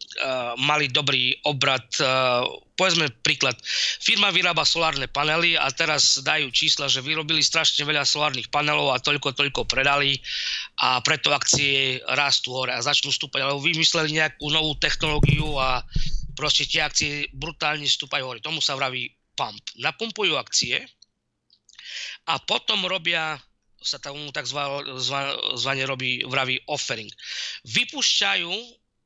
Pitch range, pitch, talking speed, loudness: 135-155 Hz, 145 Hz, 130 wpm, -22 LUFS